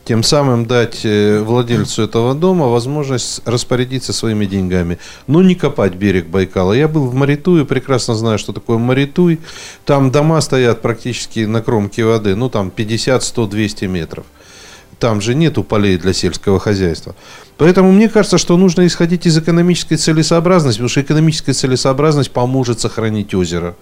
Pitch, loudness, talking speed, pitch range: 120 Hz, -14 LUFS, 145 wpm, 105-150 Hz